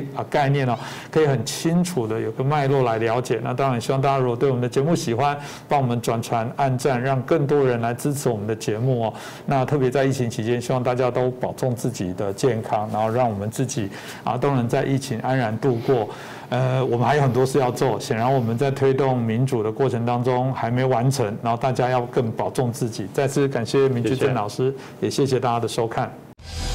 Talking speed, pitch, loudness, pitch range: 330 characters per minute, 130 Hz, -22 LUFS, 120-135 Hz